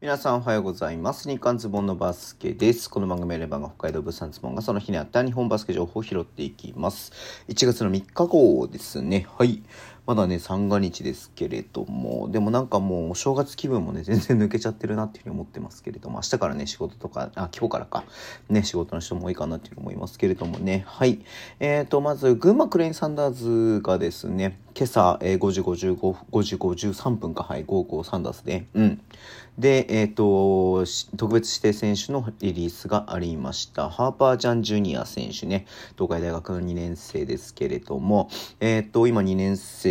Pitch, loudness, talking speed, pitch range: 105 Hz, -25 LUFS, 390 characters per minute, 95-120 Hz